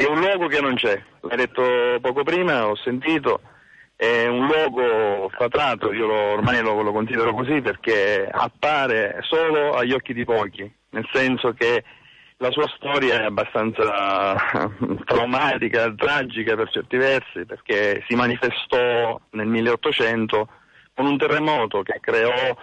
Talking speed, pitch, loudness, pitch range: 140 wpm, 125 Hz, -21 LUFS, 110-150 Hz